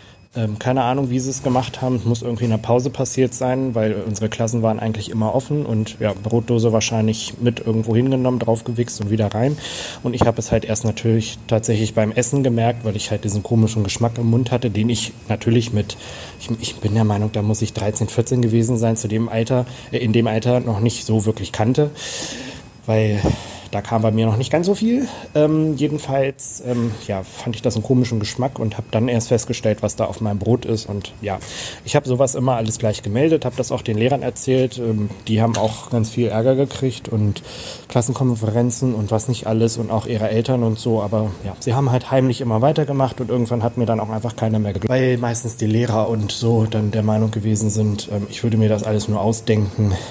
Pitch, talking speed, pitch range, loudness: 115 Hz, 220 wpm, 110-125 Hz, -19 LUFS